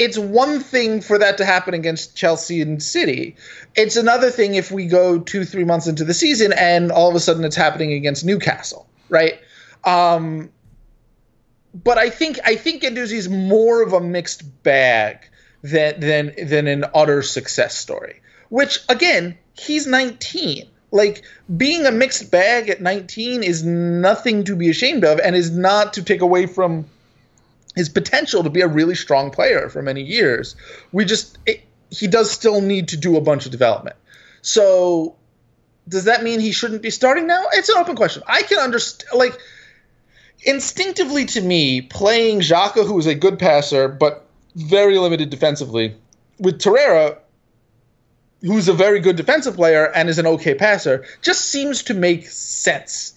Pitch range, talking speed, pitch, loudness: 160-230 Hz, 170 wpm, 185 Hz, -17 LUFS